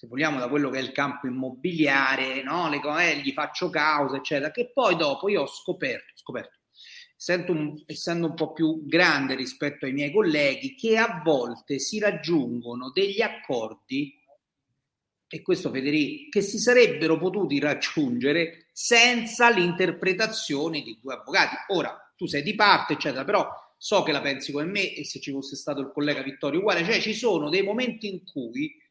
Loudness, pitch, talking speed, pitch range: -25 LUFS, 160 Hz, 170 wpm, 140-220 Hz